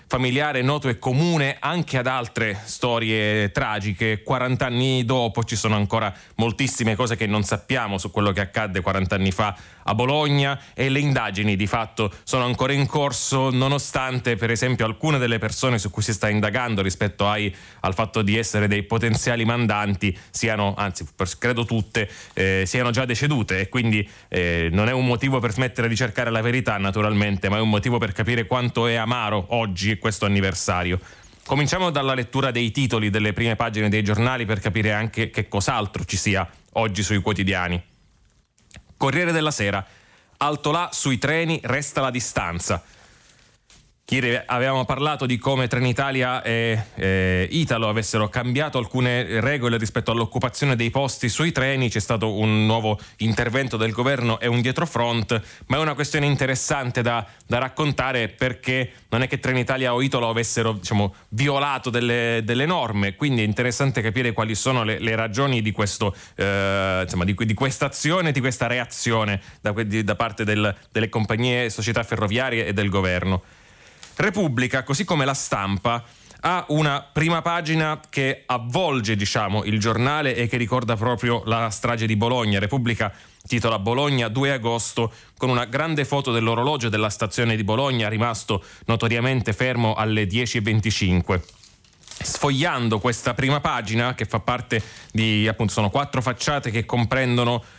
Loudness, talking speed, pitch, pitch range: -22 LUFS, 155 wpm, 115 Hz, 105-130 Hz